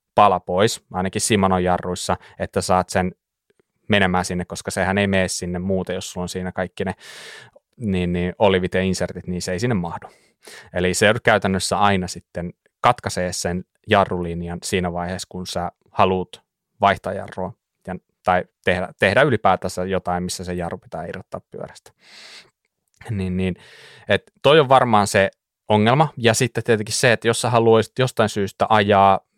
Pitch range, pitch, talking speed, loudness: 90-105 Hz, 95 Hz, 160 wpm, -20 LUFS